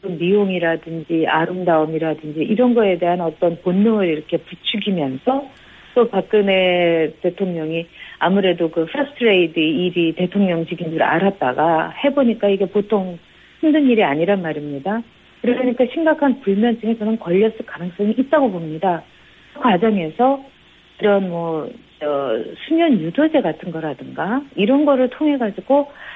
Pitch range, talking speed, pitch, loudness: 165-240 Hz, 315 characters per minute, 195 Hz, -18 LUFS